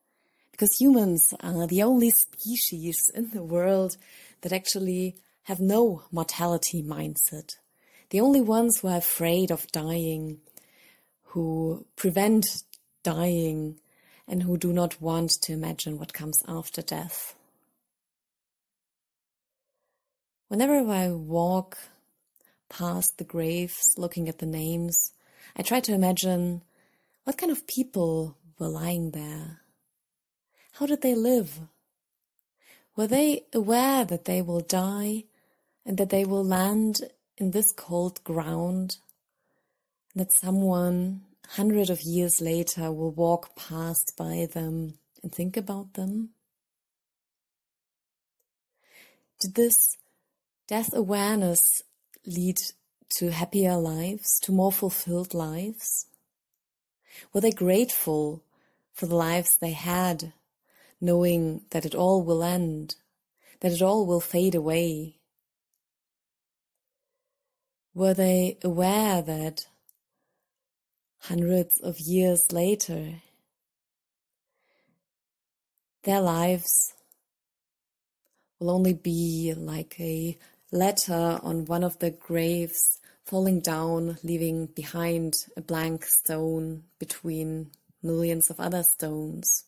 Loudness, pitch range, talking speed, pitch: -25 LUFS, 165-200 Hz, 105 wpm, 175 Hz